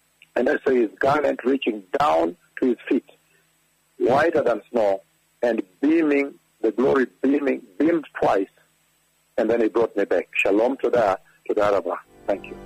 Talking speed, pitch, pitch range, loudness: 165 wpm, 140 Hz, 115-170 Hz, -22 LUFS